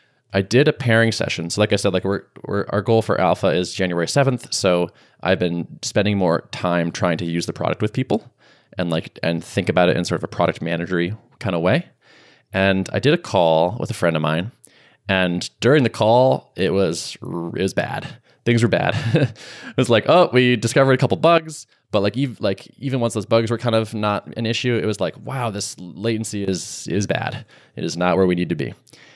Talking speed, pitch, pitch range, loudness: 225 wpm, 105 Hz, 90-120 Hz, -20 LUFS